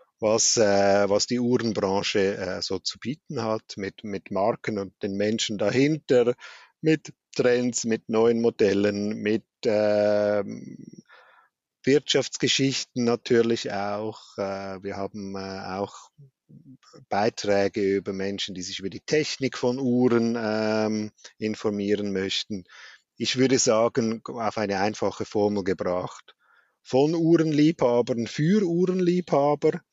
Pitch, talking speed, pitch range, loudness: 110 Hz, 115 wpm, 100-130 Hz, -25 LUFS